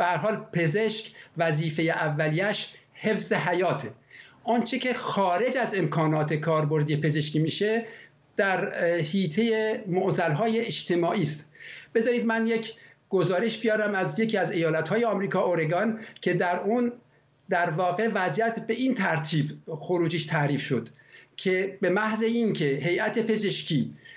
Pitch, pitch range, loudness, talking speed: 185 Hz, 160-220 Hz, -26 LUFS, 120 wpm